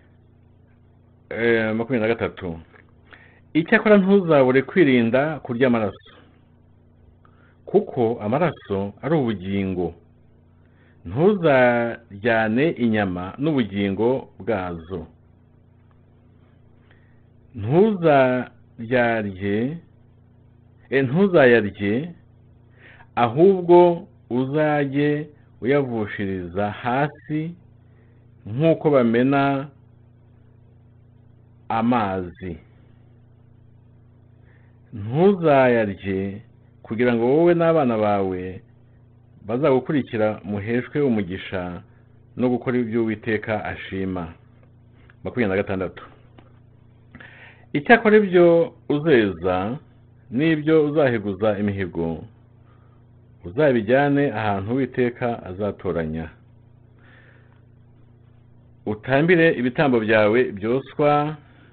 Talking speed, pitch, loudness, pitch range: 55 wpm, 120 Hz, -20 LUFS, 110-125 Hz